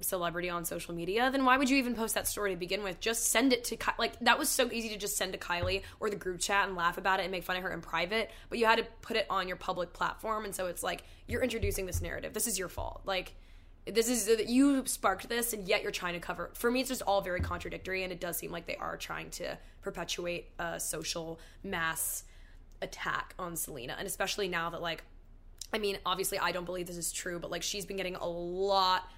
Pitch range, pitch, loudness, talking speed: 170-215 Hz, 190 Hz, -33 LUFS, 255 wpm